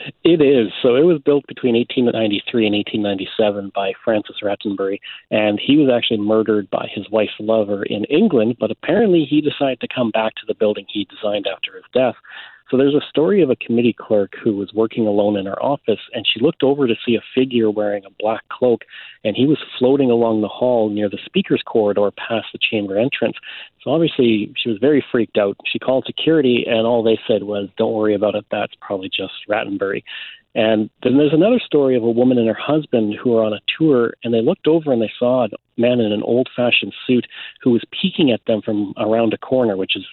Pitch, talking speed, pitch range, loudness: 115 Hz, 215 wpm, 105-130 Hz, -18 LUFS